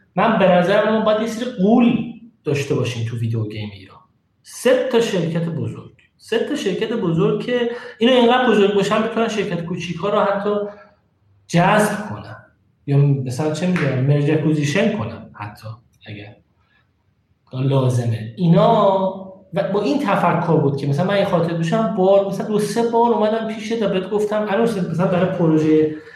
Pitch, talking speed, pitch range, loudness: 190 Hz, 160 wpm, 140-215 Hz, -18 LUFS